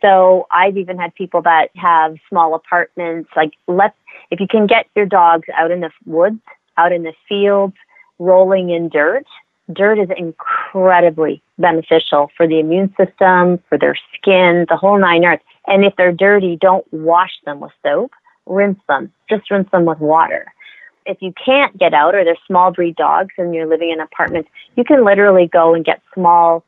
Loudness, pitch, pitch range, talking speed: -13 LUFS, 180 Hz, 165-195 Hz, 180 wpm